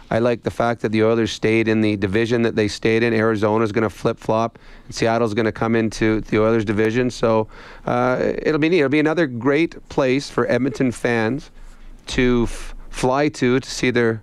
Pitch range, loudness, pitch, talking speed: 110-125 Hz, -19 LUFS, 115 Hz, 205 wpm